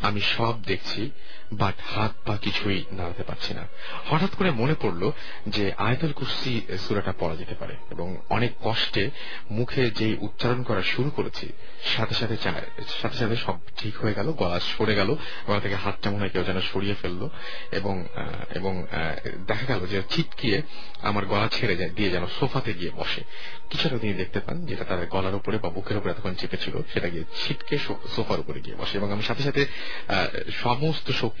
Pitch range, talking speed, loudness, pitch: 95-120 Hz, 155 wpm, -28 LUFS, 105 Hz